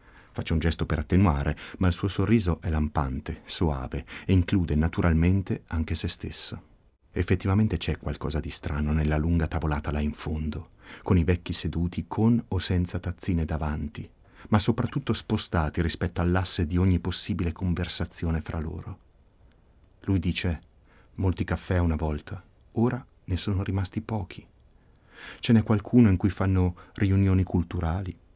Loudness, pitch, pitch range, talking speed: -27 LUFS, 90 Hz, 80-100 Hz, 145 wpm